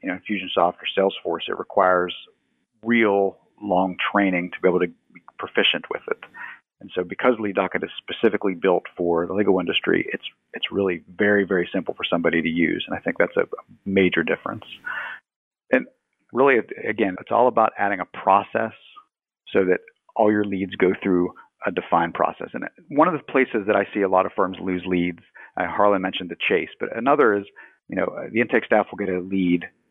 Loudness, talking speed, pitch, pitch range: -22 LUFS, 195 wpm, 95 Hz, 90-105 Hz